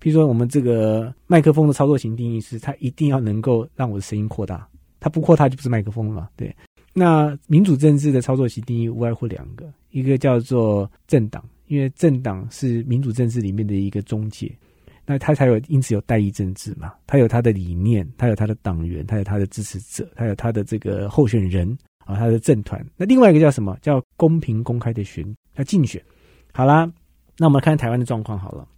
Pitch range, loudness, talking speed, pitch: 105-140 Hz, -19 LUFS, 330 characters per minute, 120 Hz